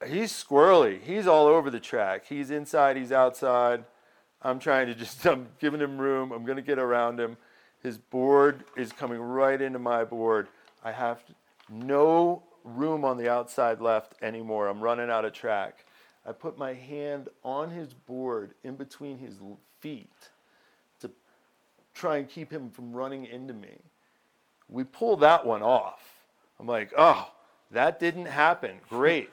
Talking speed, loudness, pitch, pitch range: 160 wpm, -26 LUFS, 130 Hz, 120-145 Hz